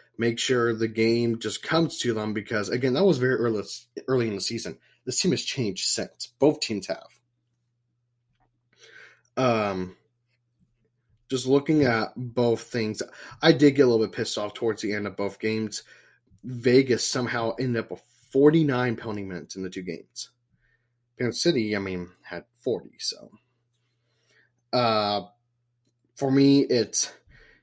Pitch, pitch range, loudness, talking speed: 120 Hz, 110-125 Hz, -25 LUFS, 150 wpm